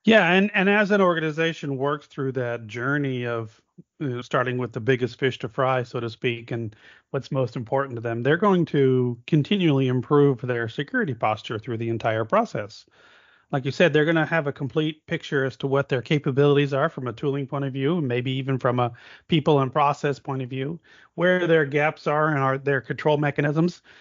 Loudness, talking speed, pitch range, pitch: -23 LUFS, 205 wpm, 125-155 Hz, 140 Hz